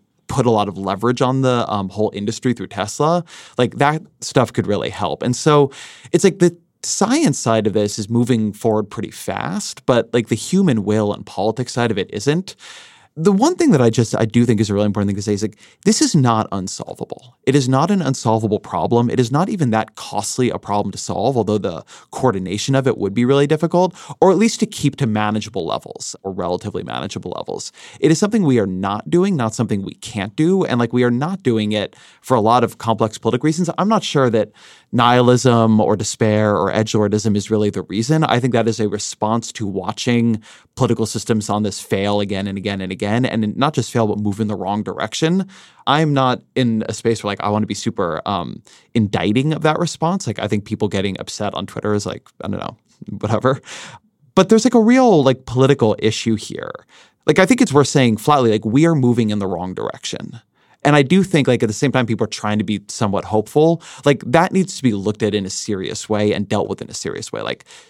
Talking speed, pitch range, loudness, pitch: 230 wpm, 105-145 Hz, -18 LUFS, 115 Hz